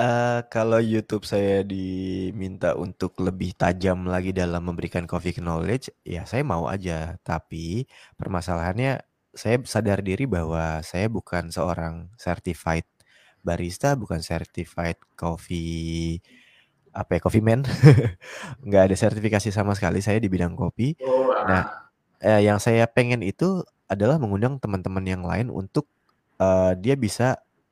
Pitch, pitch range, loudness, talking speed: 95 Hz, 85-110 Hz, -24 LUFS, 130 wpm